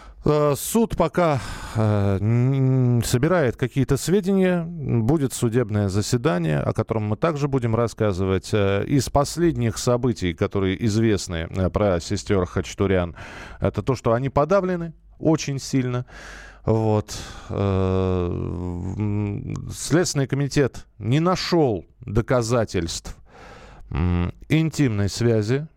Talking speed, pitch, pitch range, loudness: 85 wpm, 120 Hz, 100-140 Hz, -22 LUFS